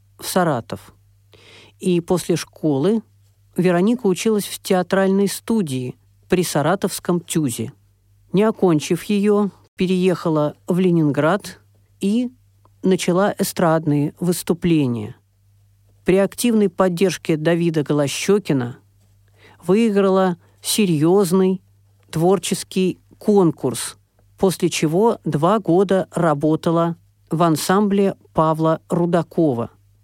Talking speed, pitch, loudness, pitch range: 80 wpm, 170 Hz, -19 LUFS, 120-190 Hz